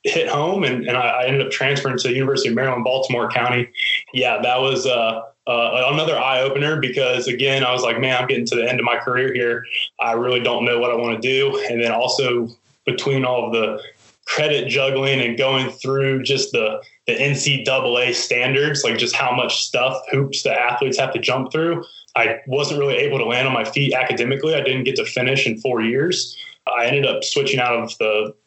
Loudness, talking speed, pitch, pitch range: -19 LUFS, 215 wpm, 130 Hz, 120-140 Hz